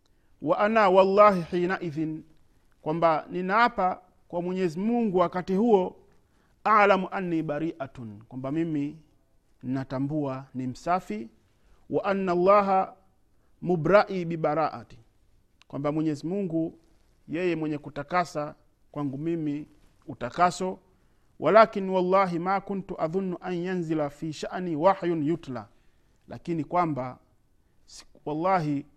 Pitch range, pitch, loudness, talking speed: 140-185 Hz, 165 Hz, -26 LUFS, 100 wpm